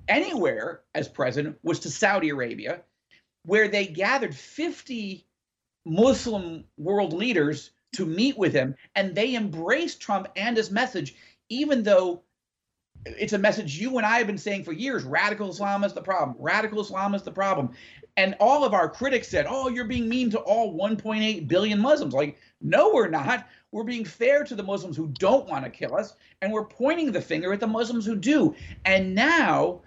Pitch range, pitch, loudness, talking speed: 190-245 Hz, 210 Hz, -25 LUFS, 185 wpm